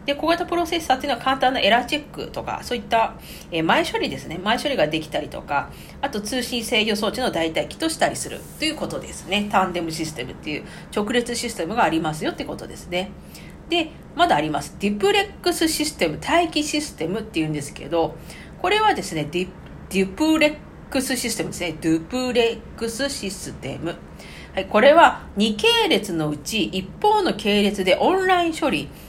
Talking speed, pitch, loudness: 400 characters per minute, 230 Hz, -22 LUFS